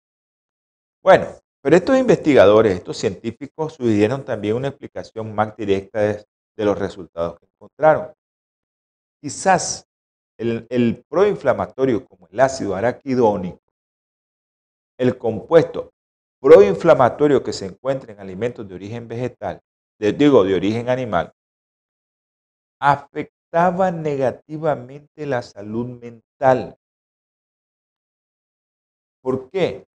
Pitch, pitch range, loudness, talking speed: 120 Hz, 100-145 Hz, -19 LUFS, 100 wpm